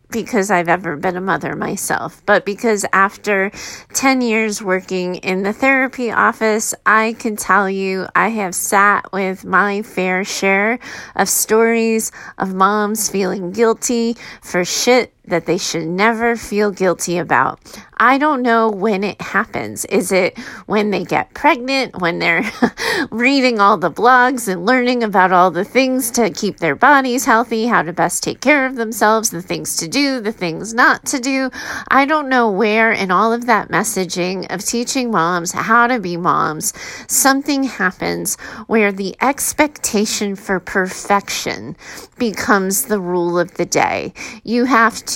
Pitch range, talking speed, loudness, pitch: 185-235 Hz, 160 wpm, -16 LUFS, 210 Hz